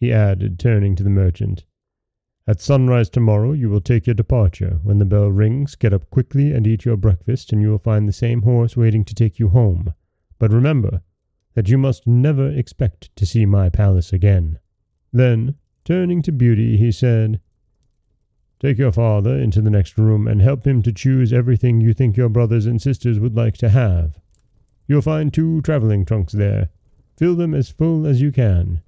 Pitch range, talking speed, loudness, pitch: 100-125 Hz, 190 wpm, -17 LUFS, 115 Hz